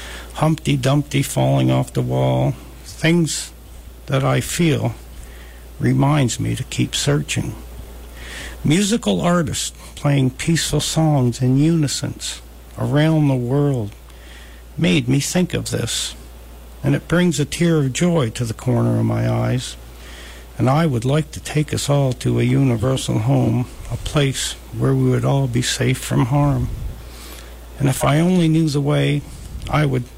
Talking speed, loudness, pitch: 145 wpm, -19 LUFS, 125 Hz